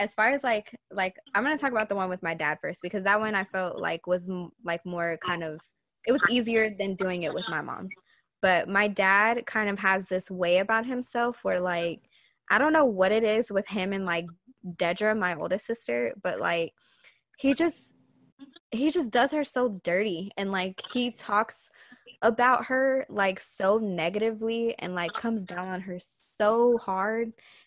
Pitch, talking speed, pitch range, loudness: 205 Hz, 195 wpm, 180-235 Hz, -27 LUFS